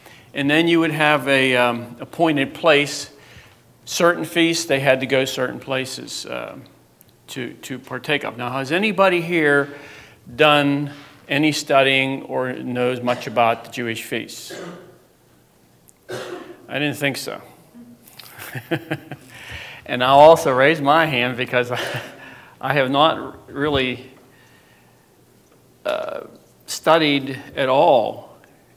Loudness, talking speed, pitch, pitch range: -19 LUFS, 115 wpm, 135 Hz, 125-150 Hz